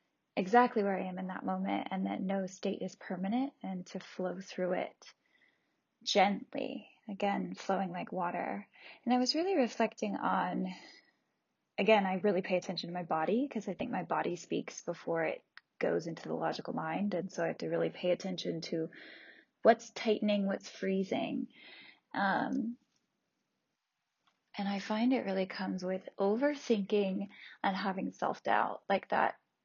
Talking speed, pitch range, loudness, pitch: 155 wpm, 185-235 Hz, -34 LUFS, 200 Hz